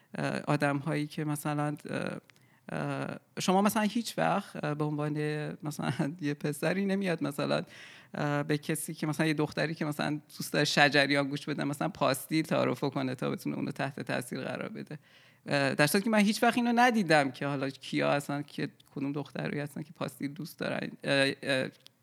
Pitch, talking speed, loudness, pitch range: 150 Hz, 160 wpm, -31 LUFS, 145-165 Hz